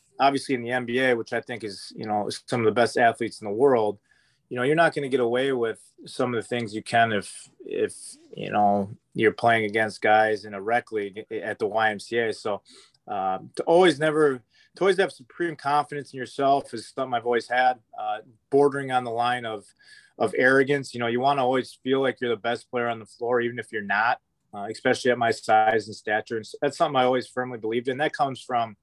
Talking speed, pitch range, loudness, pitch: 230 wpm, 110-140 Hz, -25 LUFS, 125 Hz